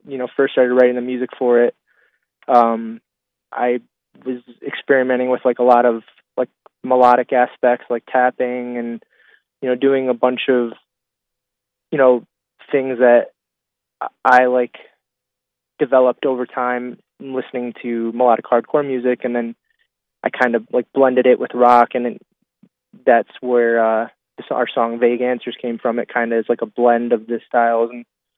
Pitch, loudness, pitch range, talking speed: 125 Hz, -17 LUFS, 120-125 Hz, 160 wpm